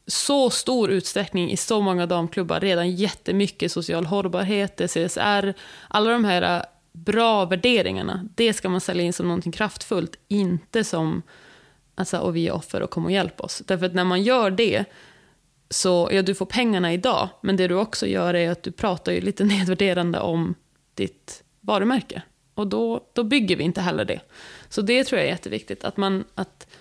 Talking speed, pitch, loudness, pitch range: 185 wpm, 190 Hz, -23 LUFS, 175-210 Hz